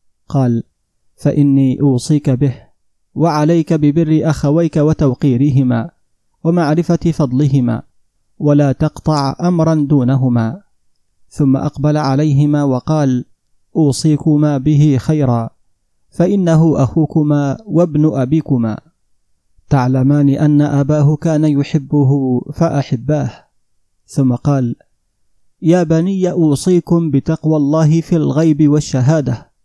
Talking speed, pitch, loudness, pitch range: 85 wpm, 145 Hz, -14 LUFS, 130-155 Hz